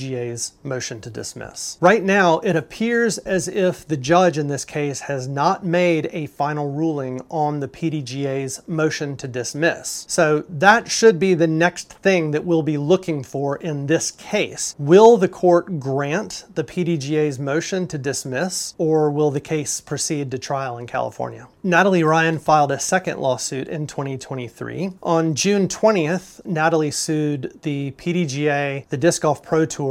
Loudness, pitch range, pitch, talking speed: -20 LUFS, 140-175 Hz, 155 Hz, 160 wpm